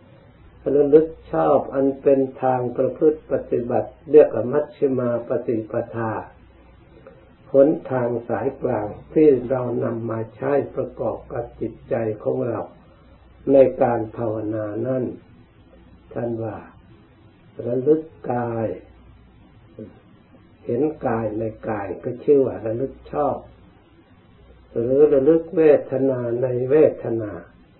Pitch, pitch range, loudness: 120 Hz, 110-135 Hz, -21 LUFS